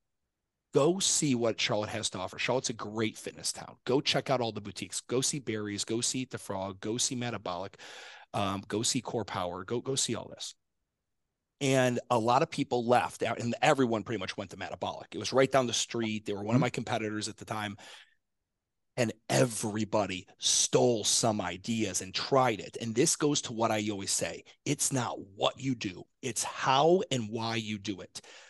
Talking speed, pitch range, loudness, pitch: 200 wpm, 105-125 Hz, -30 LUFS, 115 Hz